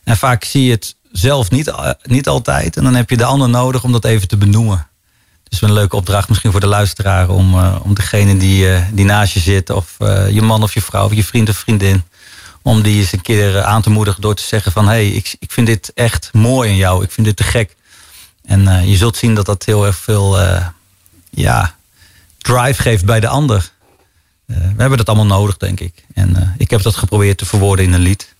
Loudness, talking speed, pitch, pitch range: -13 LUFS, 240 wpm, 105 Hz, 95-110 Hz